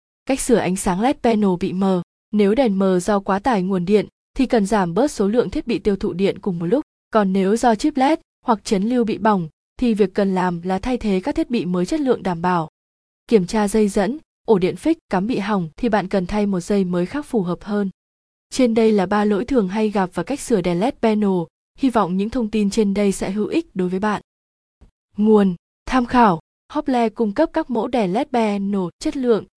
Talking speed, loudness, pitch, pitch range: 235 wpm, -20 LUFS, 210 Hz, 190-240 Hz